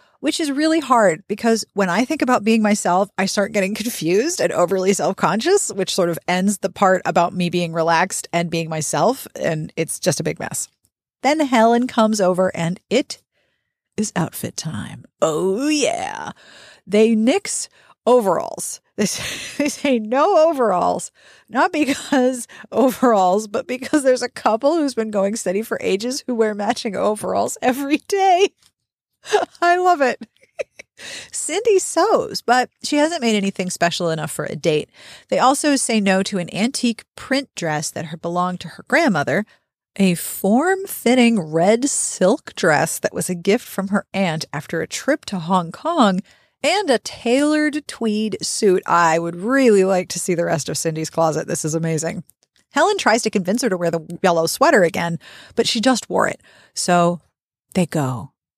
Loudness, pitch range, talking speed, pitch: -19 LUFS, 175-260 Hz, 170 wpm, 210 Hz